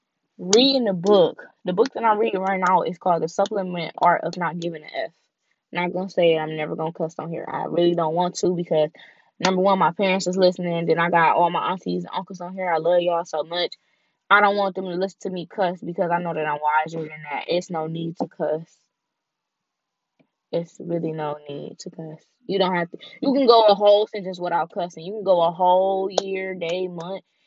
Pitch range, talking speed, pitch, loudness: 165-190 Hz, 230 wpm, 175 Hz, -22 LUFS